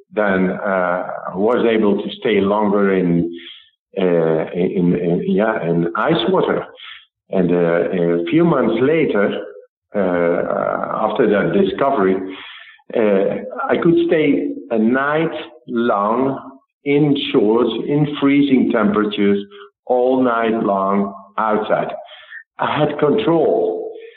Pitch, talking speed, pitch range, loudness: 105 Hz, 110 wpm, 95-145 Hz, -17 LUFS